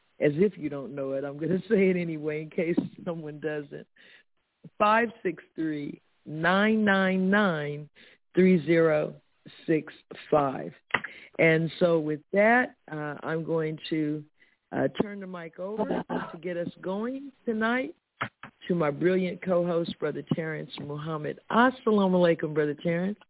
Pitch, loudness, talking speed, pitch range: 175 Hz, -27 LUFS, 120 wpm, 155-200 Hz